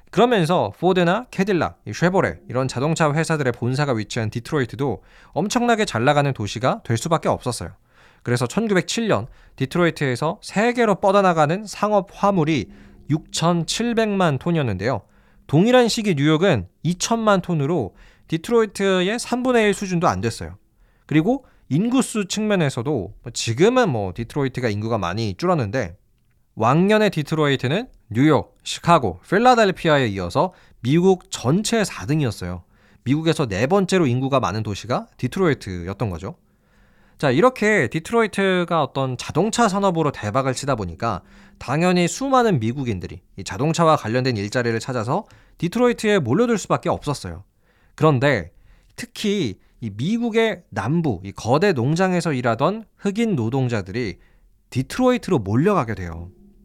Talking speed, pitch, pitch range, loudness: 325 characters per minute, 150 Hz, 115-190 Hz, -20 LUFS